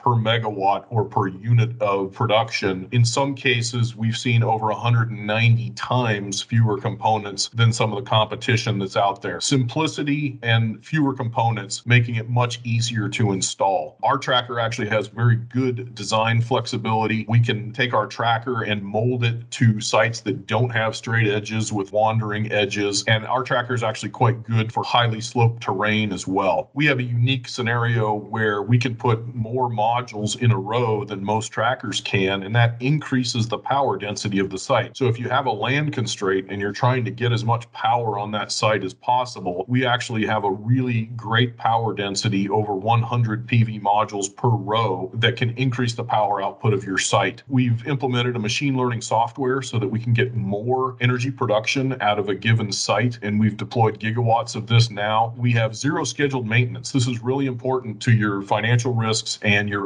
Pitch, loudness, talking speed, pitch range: 115 Hz, -21 LUFS, 185 wpm, 105-125 Hz